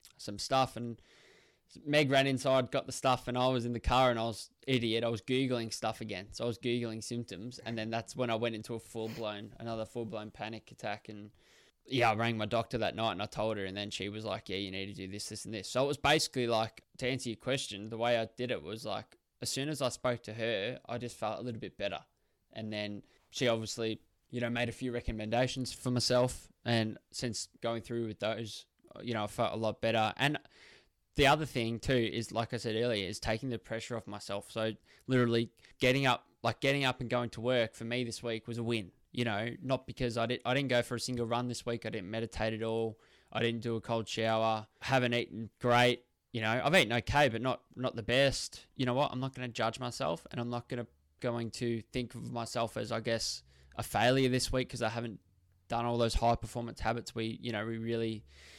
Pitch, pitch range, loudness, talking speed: 115 Hz, 110-125 Hz, -34 LUFS, 245 wpm